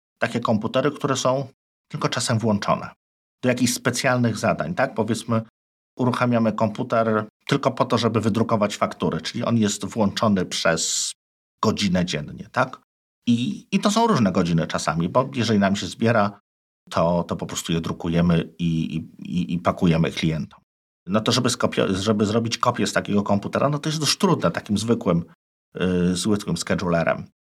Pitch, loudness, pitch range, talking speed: 110 Hz, -22 LUFS, 90-125 Hz, 155 wpm